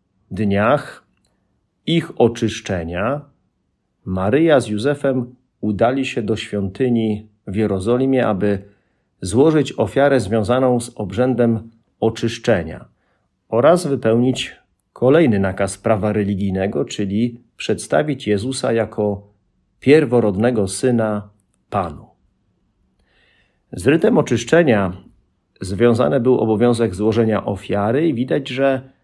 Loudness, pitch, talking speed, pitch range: -18 LUFS, 115 Hz, 90 wpm, 105-125 Hz